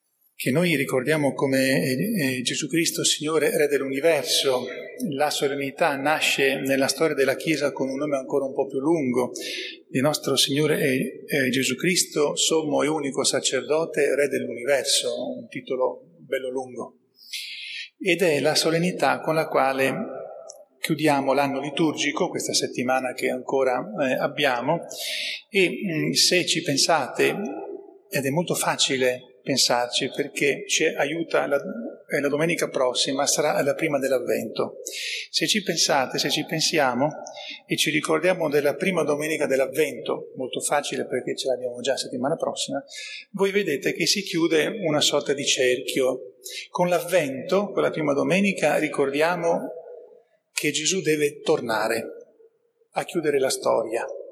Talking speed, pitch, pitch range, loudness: 135 wpm, 155 Hz, 135-185 Hz, -23 LUFS